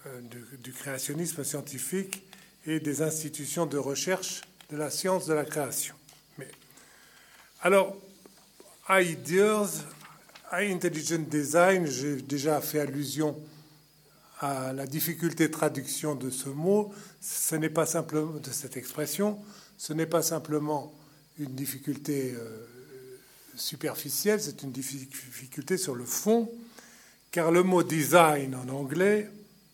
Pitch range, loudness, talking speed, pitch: 140-180 Hz, -29 LUFS, 115 wpm, 155 Hz